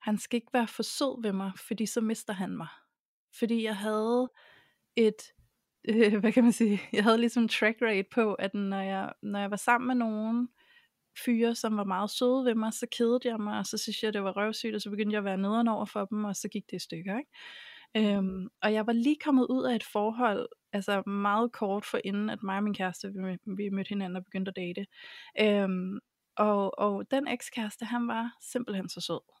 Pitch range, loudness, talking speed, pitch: 200-235 Hz, -30 LUFS, 220 wpm, 215 Hz